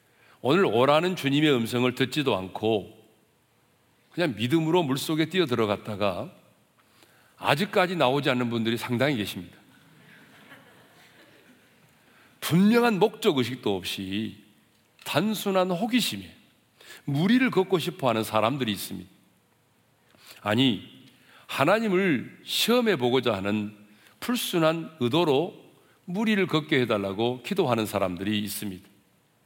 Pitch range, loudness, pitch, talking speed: 105-180 Hz, -25 LUFS, 125 Hz, 255 characters per minute